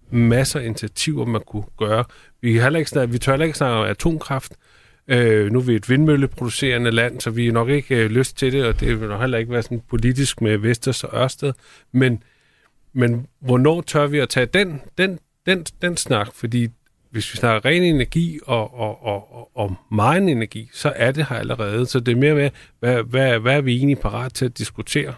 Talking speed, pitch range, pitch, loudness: 215 wpm, 115-140 Hz, 125 Hz, -20 LUFS